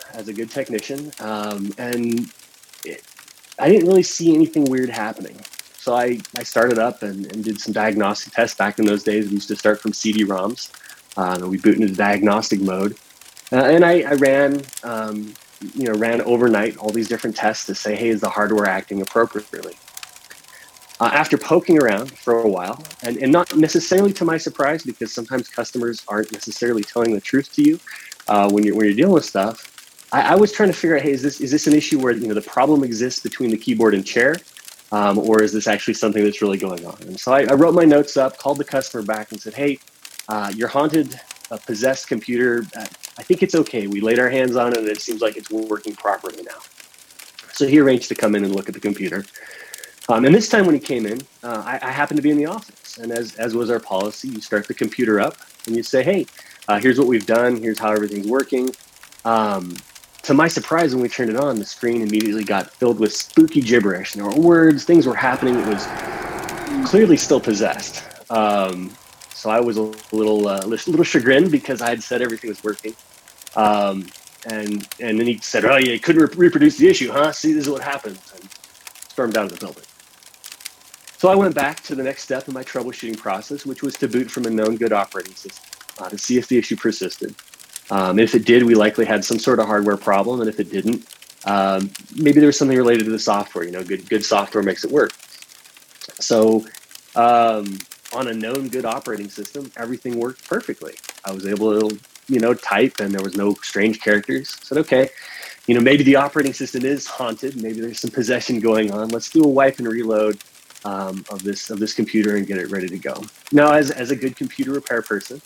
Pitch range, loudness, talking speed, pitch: 105-135 Hz, -18 LUFS, 220 wpm, 115 Hz